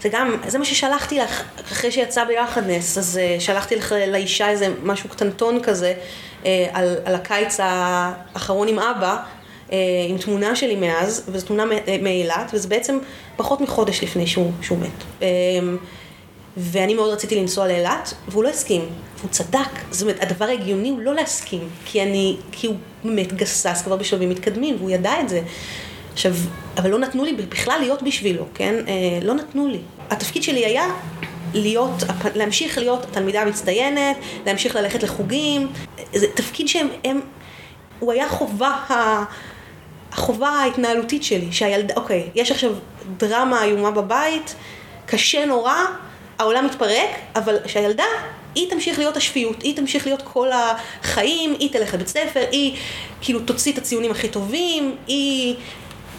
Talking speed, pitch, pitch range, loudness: 145 wpm, 215 Hz, 190-255 Hz, -20 LUFS